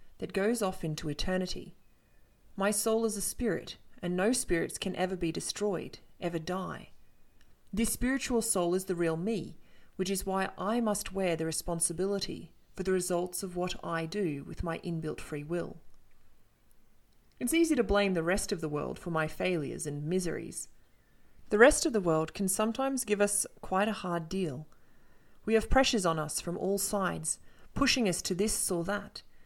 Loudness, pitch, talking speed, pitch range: -31 LUFS, 190 Hz, 175 wpm, 170-210 Hz